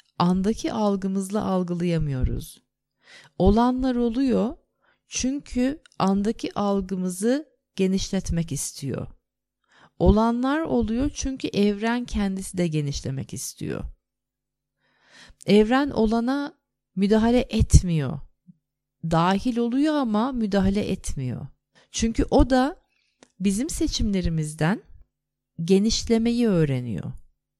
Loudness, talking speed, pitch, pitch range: -24 LUFS, 75 wpm, 210 Hz, 180-250 Hz